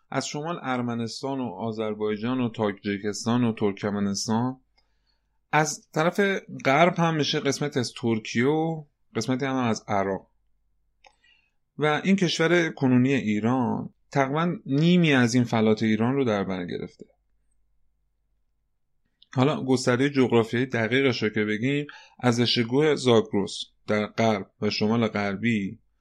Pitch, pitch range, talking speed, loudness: 125 Hz, 110-140 Hz, 120 wpm, -25 LUFS